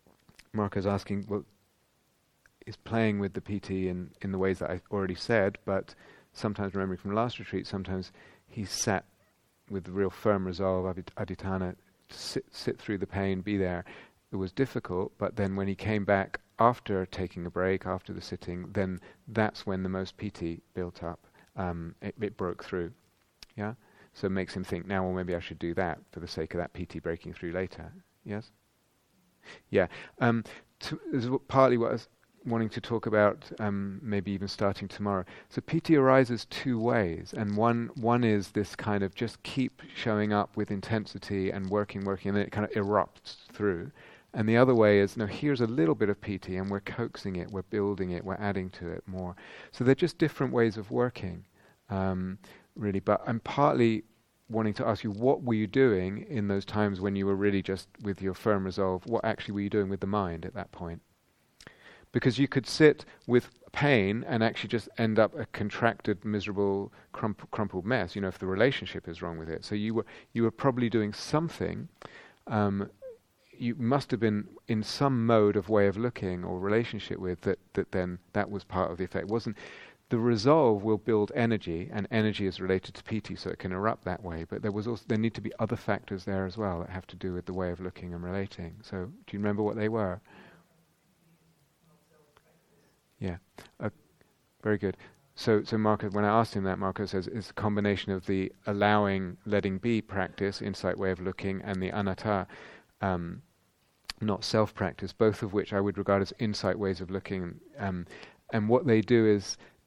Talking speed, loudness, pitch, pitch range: 205 wpm, -30 LUFS, 100 Hz, 95-110 Hz